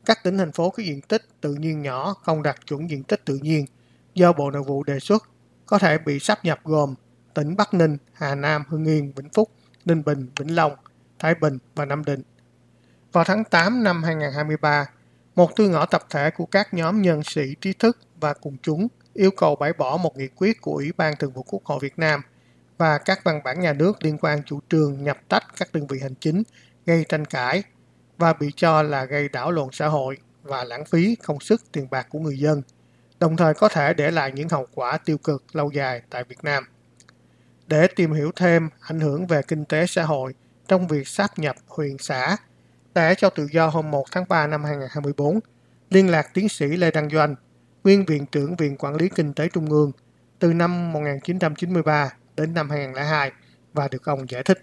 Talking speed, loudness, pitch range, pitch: 210 wpm, -22 LUFS, 145-170 Hz, 155 Hz